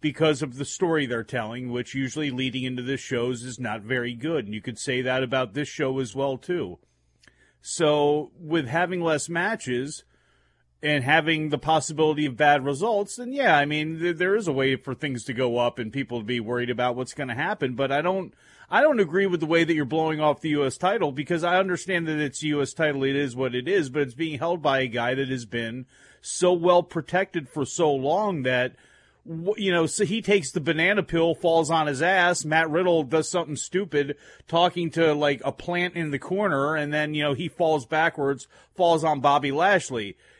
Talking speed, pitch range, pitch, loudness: 215 wpm, 130-170 Hz, 150 Hz, -24 LUFS